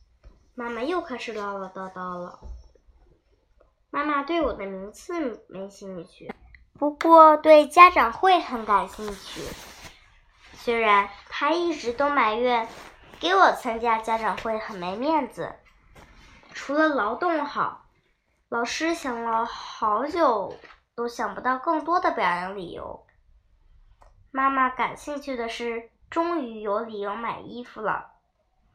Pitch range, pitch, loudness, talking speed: 210-300 Hz, 240 Hz, -23 LUFS, 185 characters per minute